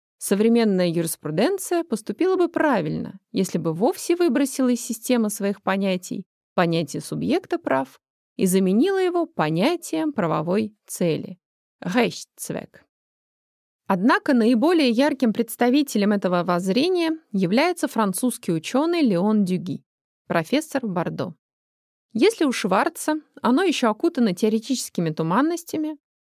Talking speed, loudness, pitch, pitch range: 100 wpm, -22 LUFS, 225 Hz, 185-300 Hz